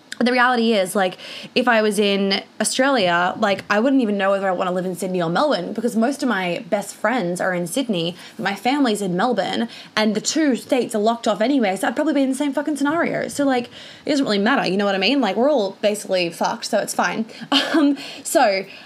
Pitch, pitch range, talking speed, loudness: 225 Hz, 195-270 Hz, 240 wpm, -20 LUFS